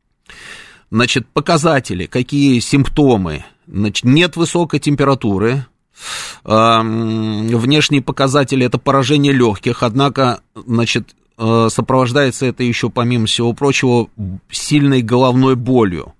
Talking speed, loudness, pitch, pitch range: 95 wpm, -14 LUFS, 125 Hz, 115-140 Hz